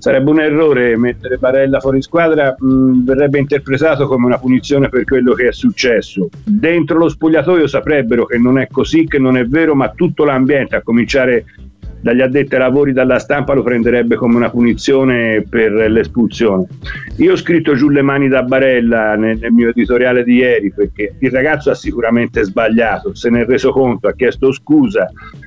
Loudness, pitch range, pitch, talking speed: -12 LUFS, 120-145 Hz, 130 Hz, 180 wpm